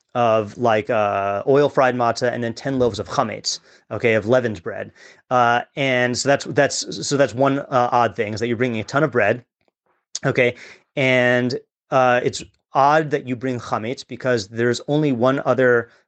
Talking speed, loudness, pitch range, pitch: 185 wpm, -19 LUFS, 120-135 Hz, 125 Hz